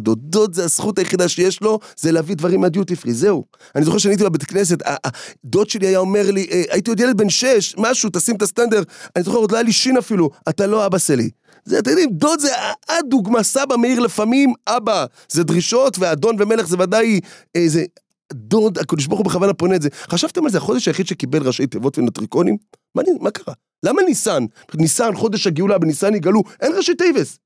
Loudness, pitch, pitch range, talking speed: -17 LUFS, 200 Hz, 175-230 Hz, 190 wpm